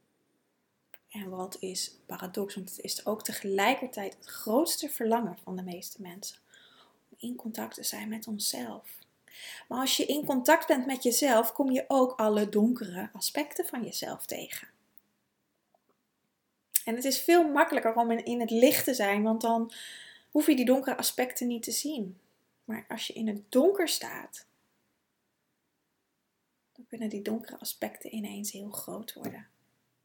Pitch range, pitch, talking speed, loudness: 210-265 Hz, 230 Hz, 155 wpm, -29 LUFS